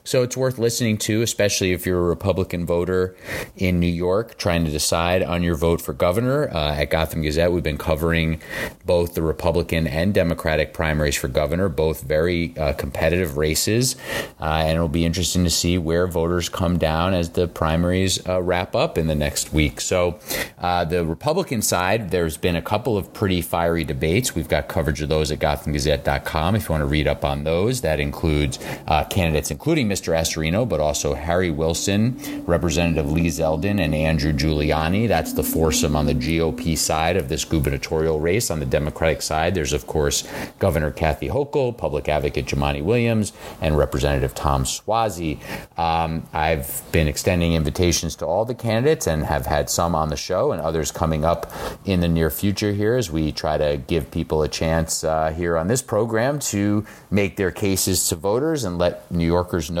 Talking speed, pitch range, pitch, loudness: 190 wpm, 80-90 Hz, 85 Hz, -21 LUFS